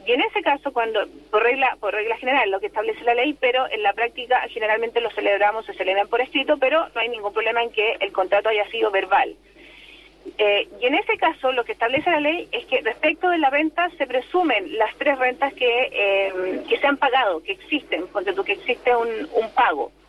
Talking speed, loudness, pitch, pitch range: 215 wpm, -21 LUFS, 250 Hz, 220-320 Hz